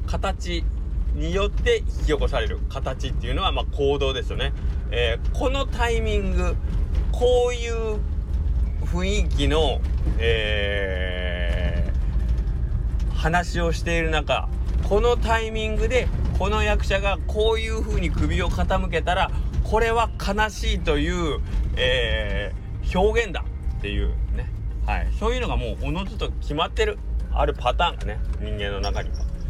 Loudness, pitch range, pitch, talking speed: -24 LUFS, 70-100 Hz, 75 Hz, 265 characters per minute